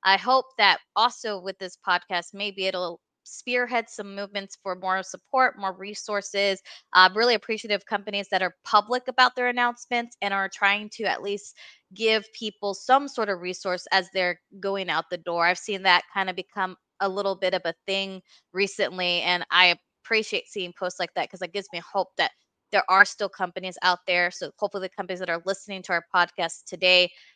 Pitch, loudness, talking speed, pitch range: 195 Hz, -25 LUFS, 195 wpm, 185-210 Hz